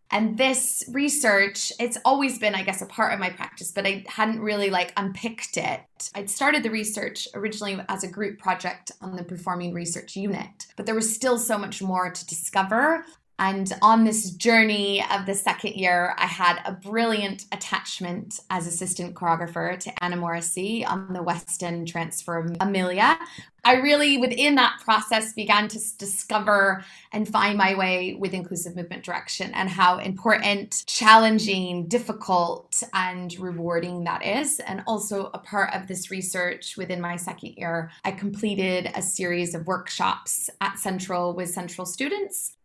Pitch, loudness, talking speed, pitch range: 195 Hz, -24 LUFS, 160 wpm, 180-220 Hz